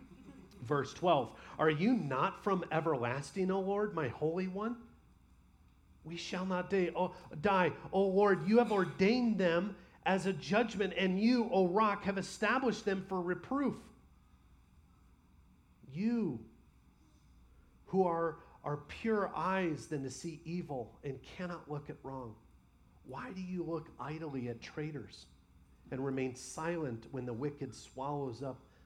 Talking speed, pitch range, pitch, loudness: 135 wpm, 135-195 Hz, 165 Hz, -35 LUFS